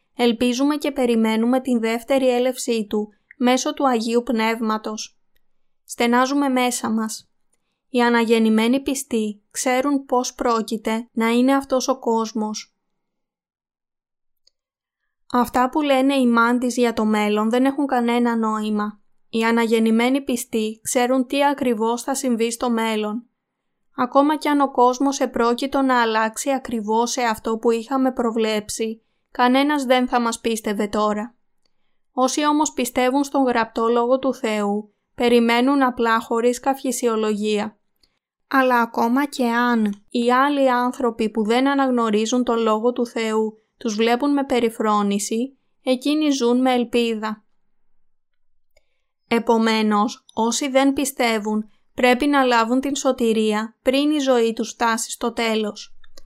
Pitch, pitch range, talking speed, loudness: 240 Hz, 225-260 Hz, 125 wpm, -20 LUFS